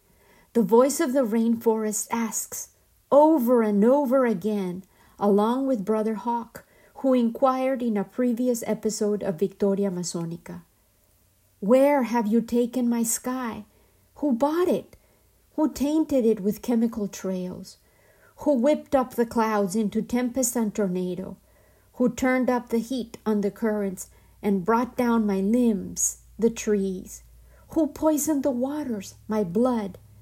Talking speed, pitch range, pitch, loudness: 135 wpm, 205-255 Hz, 230 Hz, -24 LUFS